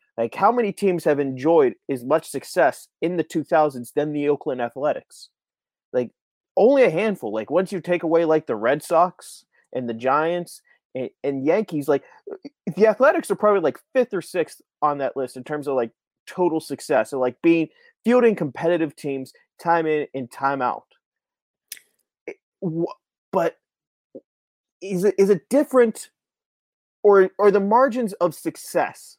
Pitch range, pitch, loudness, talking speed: 145-205 Hz, 165 Hz, -22 LUFS, 160 wpm